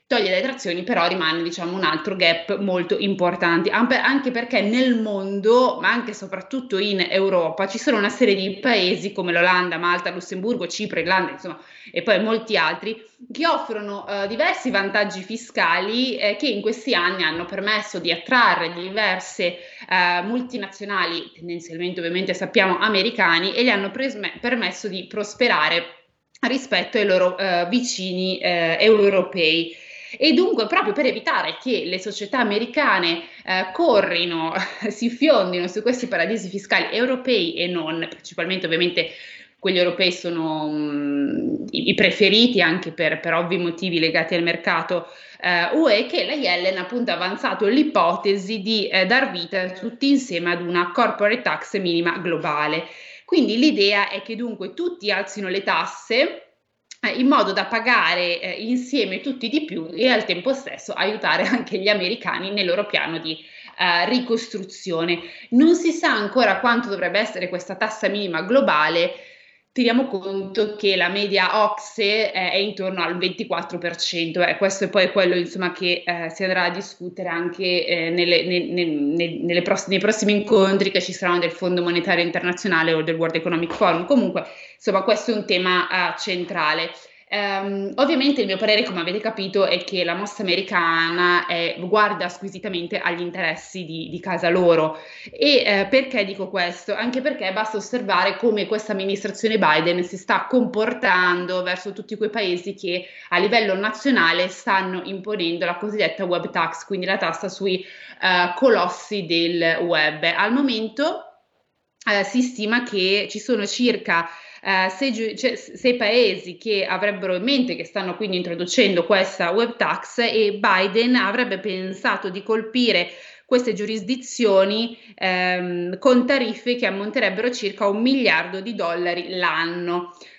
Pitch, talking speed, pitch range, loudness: 195 Hz, 155 wpm, 175-225 Hz, -21 LUFS